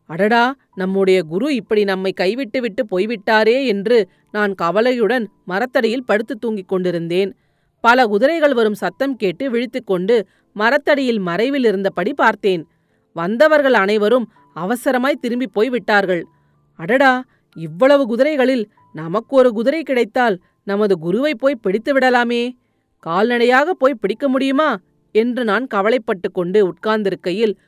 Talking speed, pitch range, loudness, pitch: 110 wpm, 190-255 Hz, -17 LUFS, 225 Hz